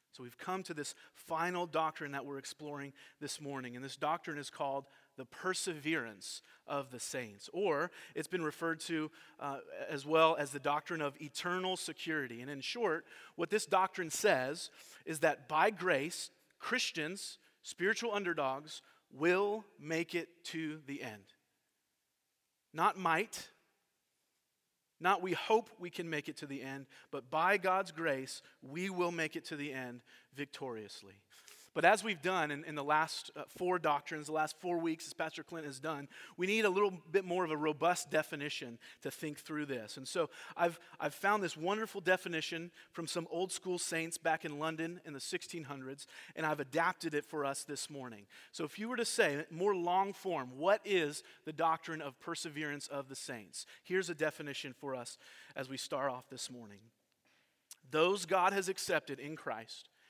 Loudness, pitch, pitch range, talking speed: -37 LUFS, 160 Hz, 140-175 Hz, 175 wpm